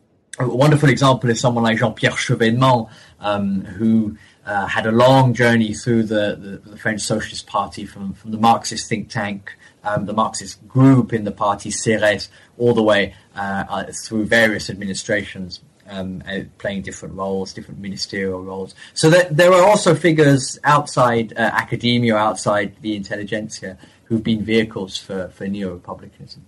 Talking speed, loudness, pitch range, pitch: 160 wpm, -18 LUFS, 100-120 Hz, 110 Hz